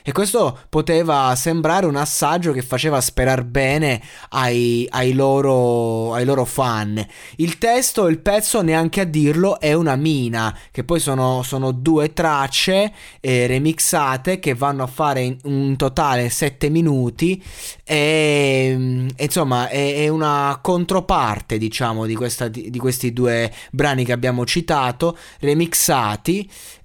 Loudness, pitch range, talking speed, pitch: -18 LUFS, 125-160 Hz, 135 wpm, 140 Hz